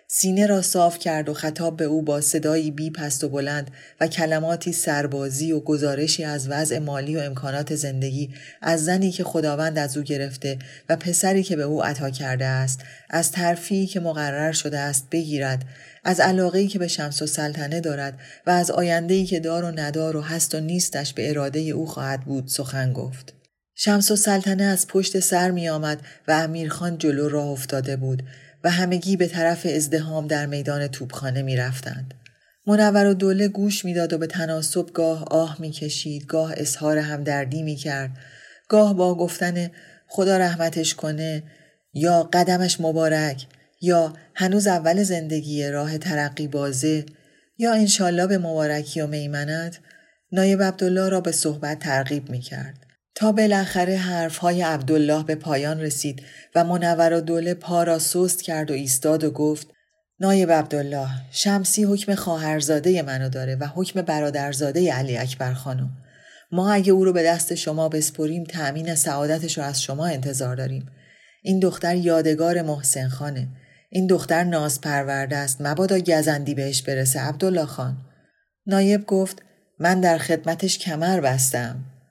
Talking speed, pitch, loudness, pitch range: 155 wpm, 155 Hz, -22 LUFS, 145-175 Hz